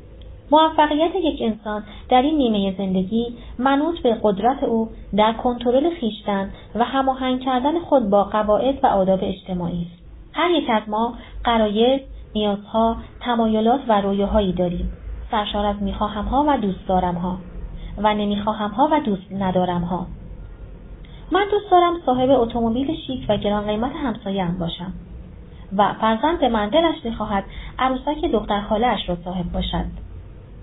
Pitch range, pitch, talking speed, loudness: 195-260 Hz, 215 Hz, 145 wpm, -21 LUFS